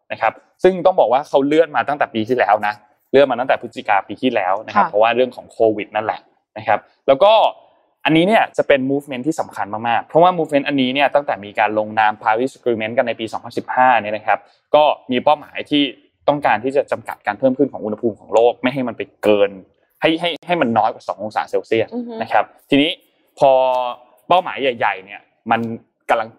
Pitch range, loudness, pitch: 110-145 Hz, -17 LUFS, 130 Hz